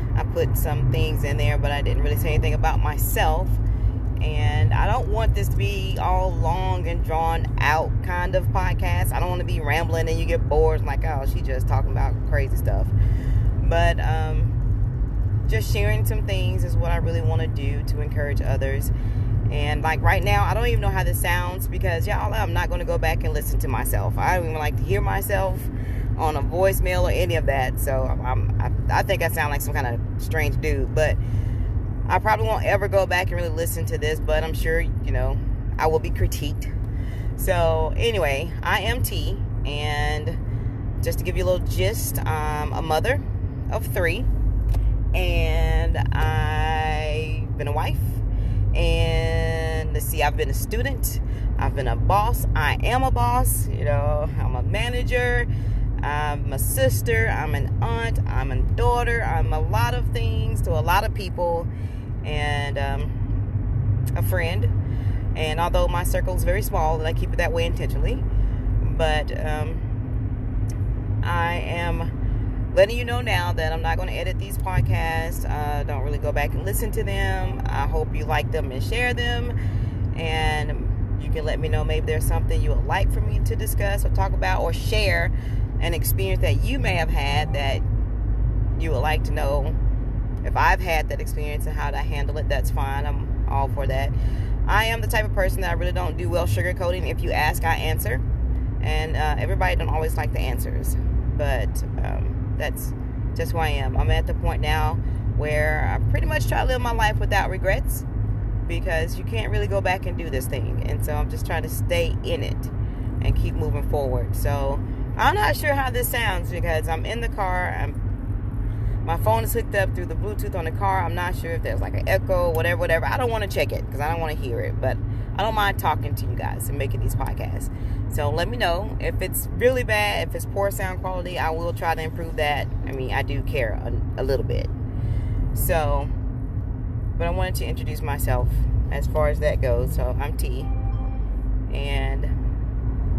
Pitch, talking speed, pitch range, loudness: 105 Hz, 195 wpm, 100-115 Hz, -24 LUFS